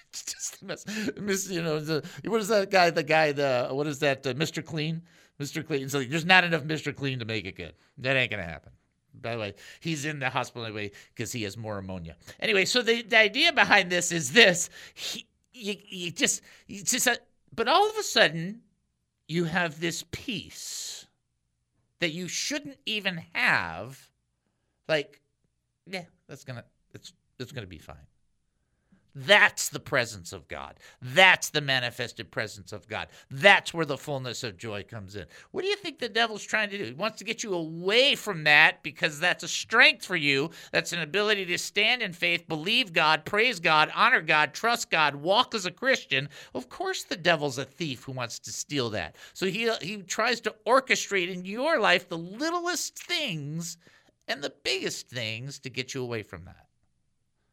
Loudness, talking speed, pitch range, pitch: -26 LUFS, 190 wpm, 130-205 Hz, 165 Hz